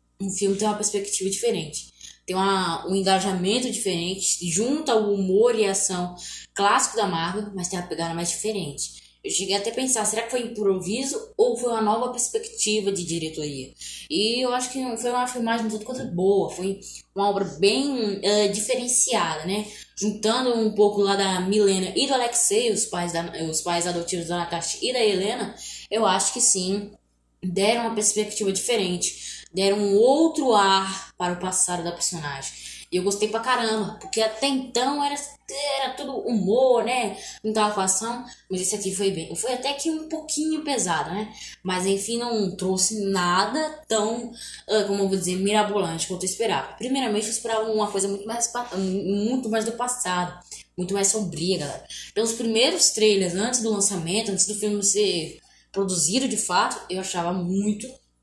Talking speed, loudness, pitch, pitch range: 175 wpm, -23 LUFS, 205 Hz, 190-235 Hz